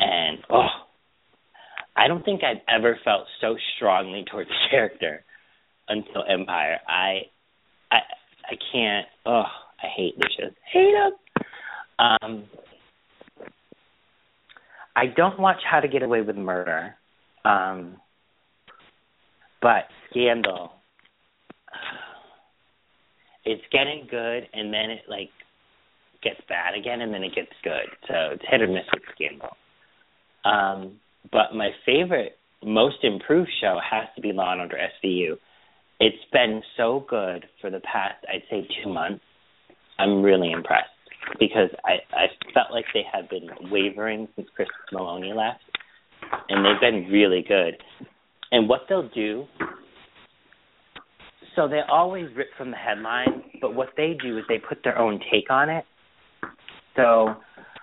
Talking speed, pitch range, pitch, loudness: 135 wpm, 105-145 Hz, 115 Hz, -23 LUFS